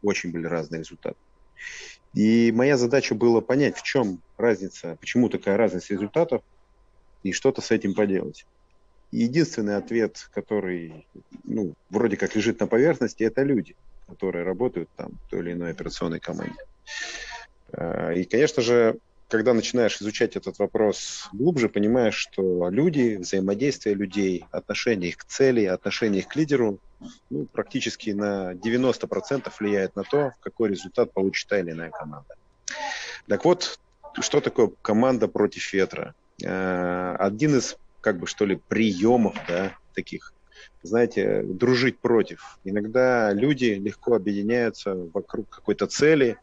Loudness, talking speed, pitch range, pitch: -24 LUFS, 135 wpm, 95-120 Hz, 105 Hz